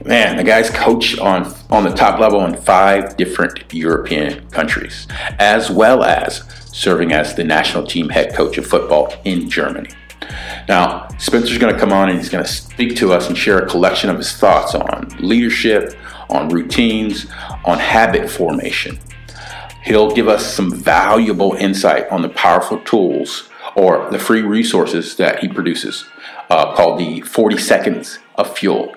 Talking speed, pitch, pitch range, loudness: 165 wpm, 105 Hz, 95-115 Hz, -14 LUFS